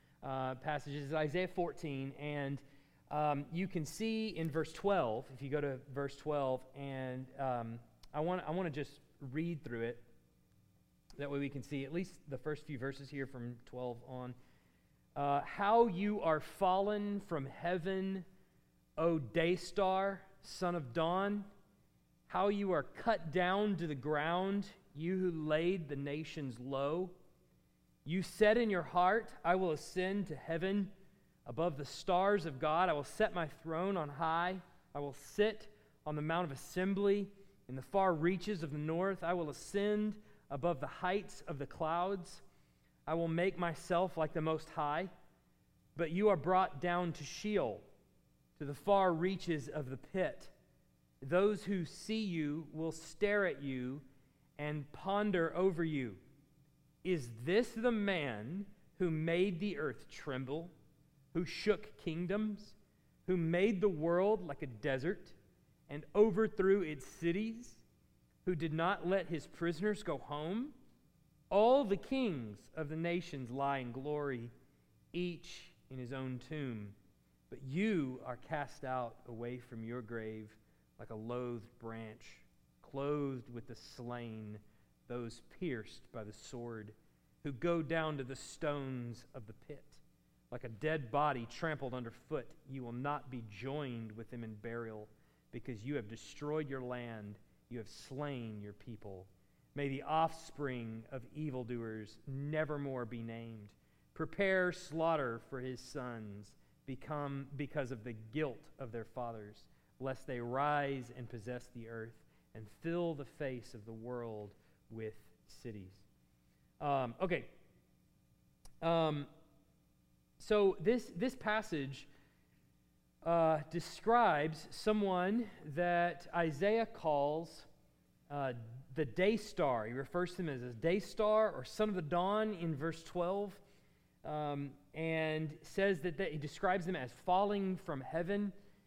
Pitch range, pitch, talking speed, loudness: 125-180 Hz, 150 Hz, 145 wpm, -38 LUFS